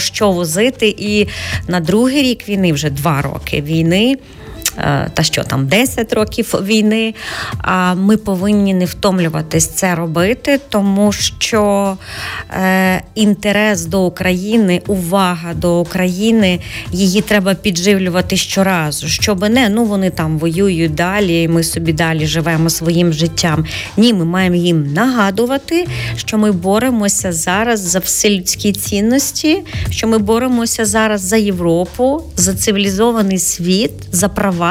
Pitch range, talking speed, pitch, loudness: 175-215 Hz, 130 wpm, 195 Hz, -14 LUFS